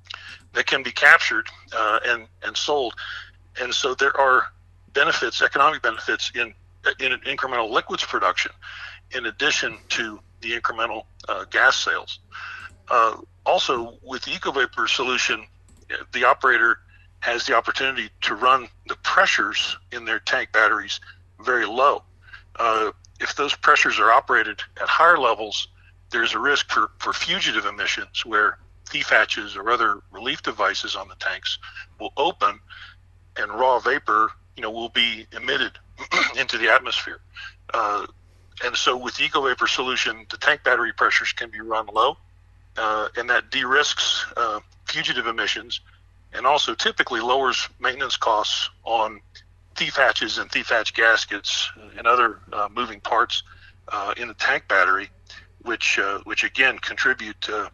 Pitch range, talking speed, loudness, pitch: 90-105 Hz, 145 wpm, -21 LUFS, 90 Hz